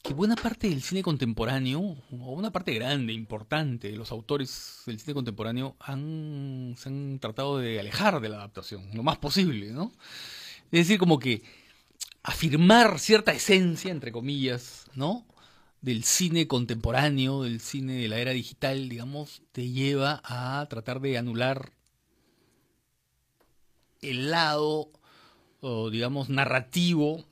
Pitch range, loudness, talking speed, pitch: 120-155 Hz, -27 LUFS, 135 wpm, 135 Hz